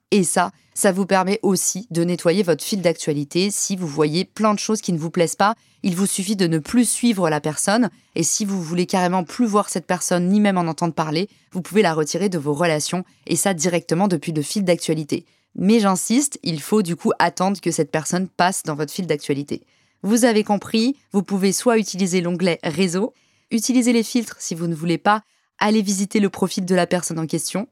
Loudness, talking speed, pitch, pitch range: -20 LUFS, 215 wpm, 185 Hz, 170-205 Hz